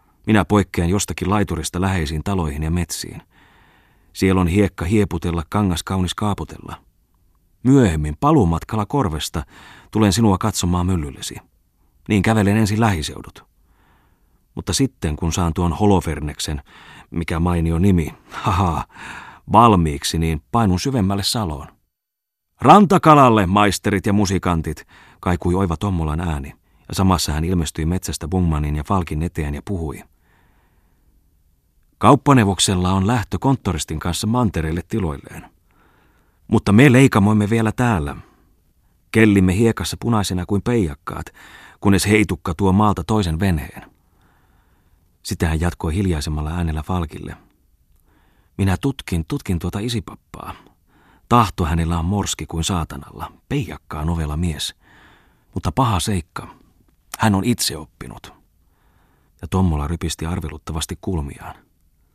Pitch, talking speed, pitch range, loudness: 90 Hz, 110 wpm, 80-105 Hz, -19 LUFS